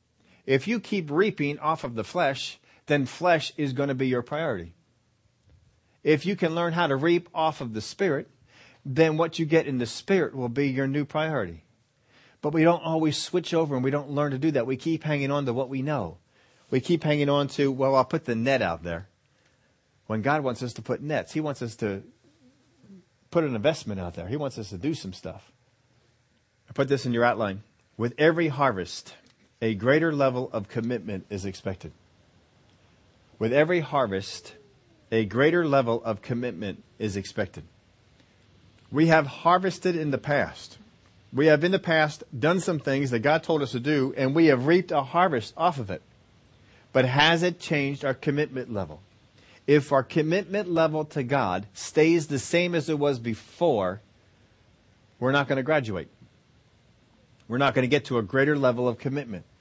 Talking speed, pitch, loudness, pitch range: 185 wpm, 135 Hz, -26 LUFS, 110-155 Hz